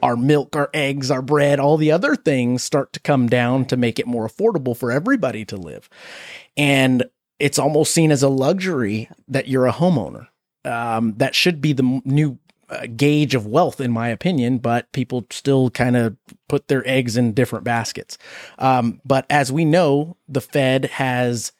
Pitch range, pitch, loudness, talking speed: 125-145 Hz, 135 Hz, -19 LUFS, 185 wpm